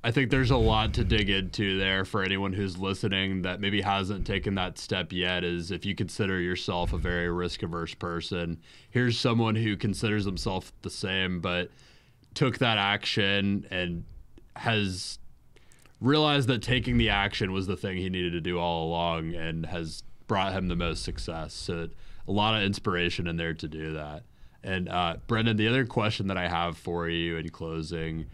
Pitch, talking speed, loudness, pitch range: 95 Hz, 185 wpm, -28 LUFS, 85-110 Hz